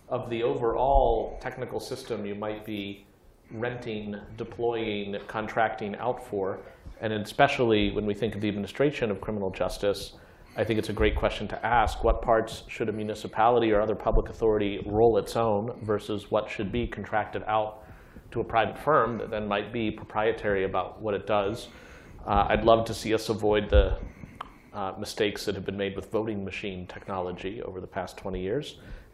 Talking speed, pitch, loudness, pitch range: 175 wpm, 105 Hz, -28 LUFS, 100-115 Hz